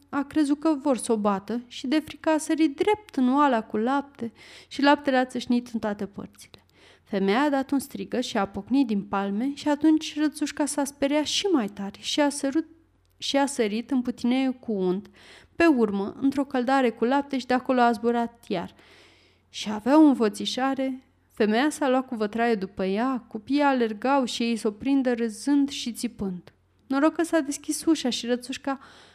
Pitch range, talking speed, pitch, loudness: 230-285 Hz, 185 wpm, 260 Hz, -25 LUFS